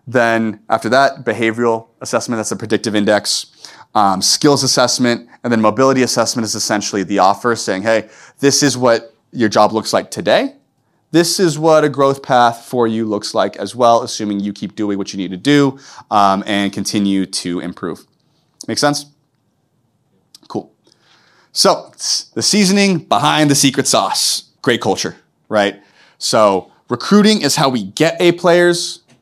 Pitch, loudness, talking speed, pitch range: 115 Hz, -15 LUFS, 160 wpm, 105-140 Hz